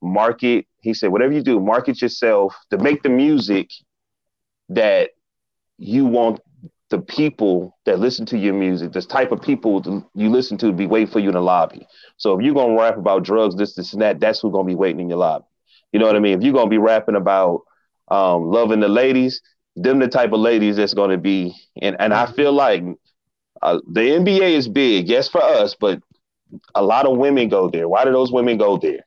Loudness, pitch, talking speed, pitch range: -17 LUFS, 110 Hz, 215 wpm, 100-130 Hz